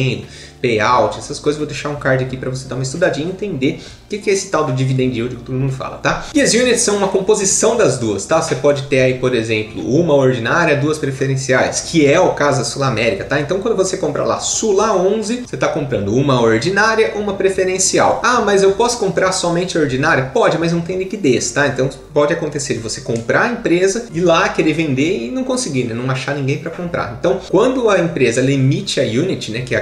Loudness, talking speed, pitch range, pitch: -16 LUFS, 230 wpm, 130-190 Hz, 150 Hz